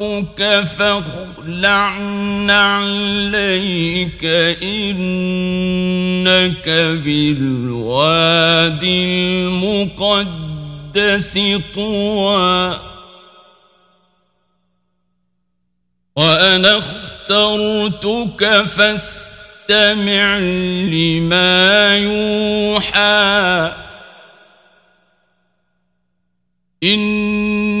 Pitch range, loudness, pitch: 165-205 Hz, -14 LUFS, 185 Hz